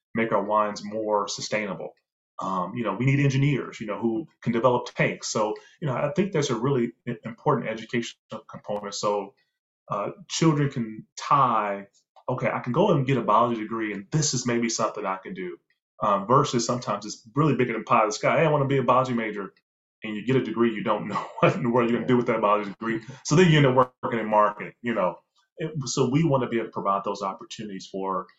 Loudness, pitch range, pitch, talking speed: -25 LUFS, 105-135 Hz, 120 Hz, 230 wpm